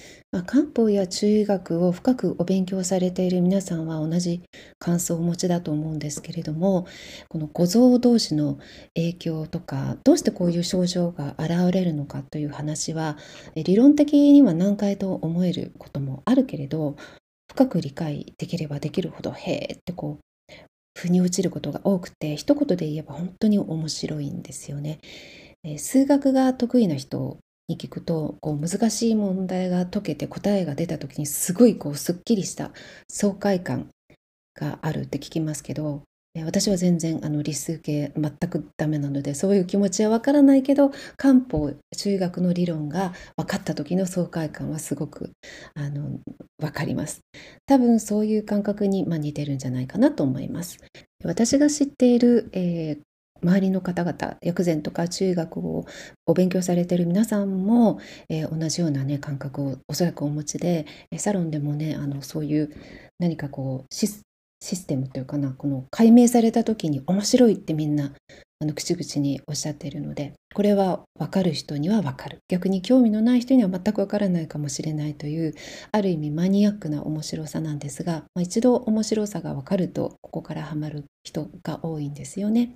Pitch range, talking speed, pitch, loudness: 150-200 Hz, 340 characters per minute, 170 Hz, -24 LUFS